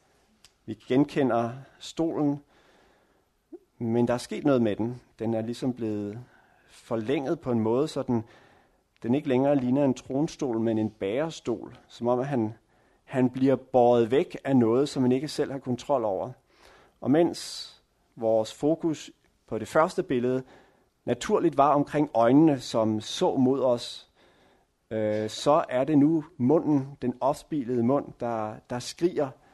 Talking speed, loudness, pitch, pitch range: 150 wpm, -26 LUFS, 125 Hz, 115-145 Hz